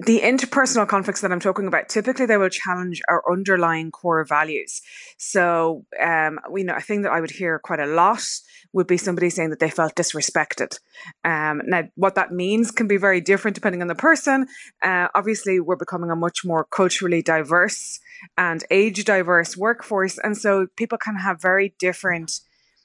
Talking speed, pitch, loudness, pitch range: 180 wpm, 185 Hz, -21 LUFS, 170-210 Hz